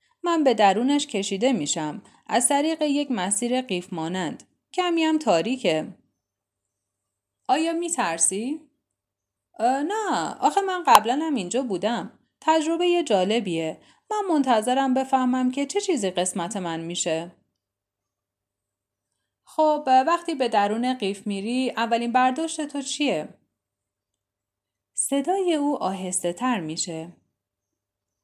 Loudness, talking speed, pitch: -24 LUFS, 110 wpm, 225 Hz